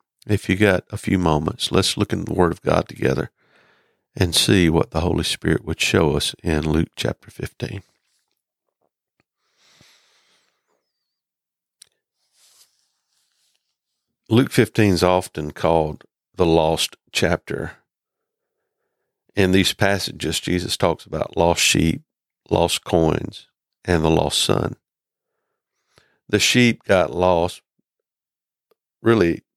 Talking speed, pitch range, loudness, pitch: 110 wpm, 80-110 Hz, -20 LUFS, 90 Hz